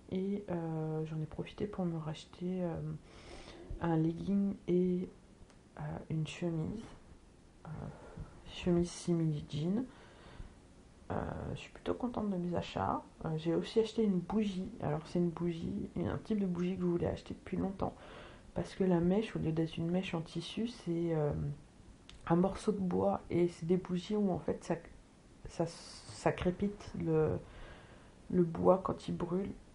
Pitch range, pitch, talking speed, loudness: 160-190 Hz, 175 Hz, 165 wpm, -36 LUFS